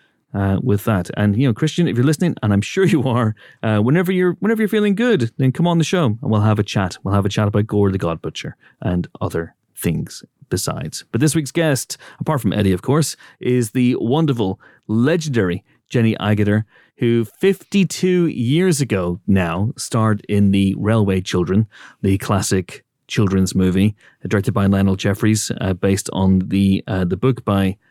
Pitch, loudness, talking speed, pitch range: 110 Hz, -18 LUFS, 185 wpm, 100-140 Hz